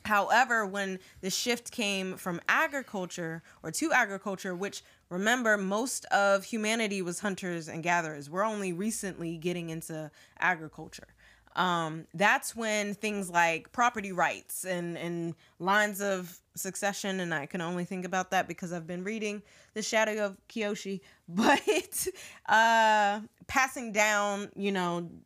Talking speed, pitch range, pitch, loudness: 140 wpm, 175-215 Hz, 195 Hz, -30 LUFS